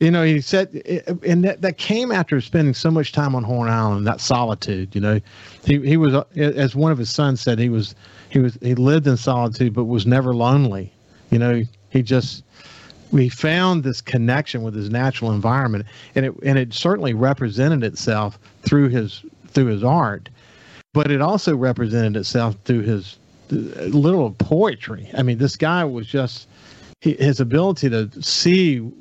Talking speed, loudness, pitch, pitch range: 170 wpm, -19 LUFS, 130 Hz, 115-145 Hz